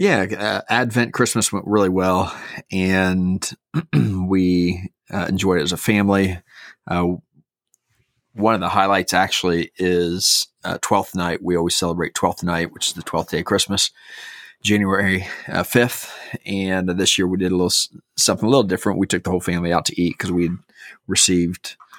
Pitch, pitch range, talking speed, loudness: 95 Hz, 90-100 Hz, 170 wpm, -19 LUFS